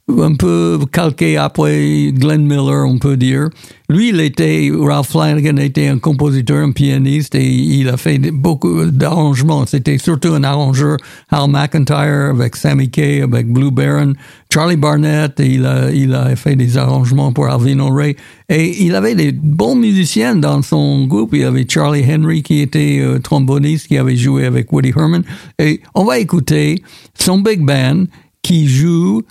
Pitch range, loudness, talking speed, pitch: 135-155 Hz, -12 LUFS, 170 wpm, 145 Hz